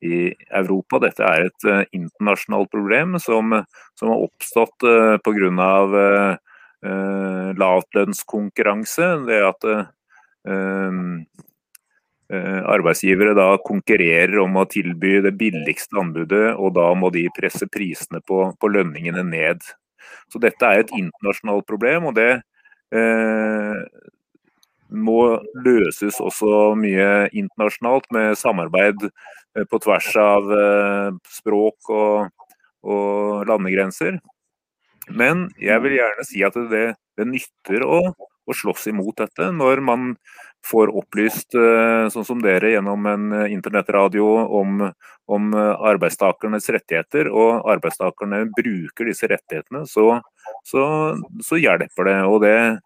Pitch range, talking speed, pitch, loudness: 95-110 Hz, 115 wpm, 105 Hz, -18 LUFS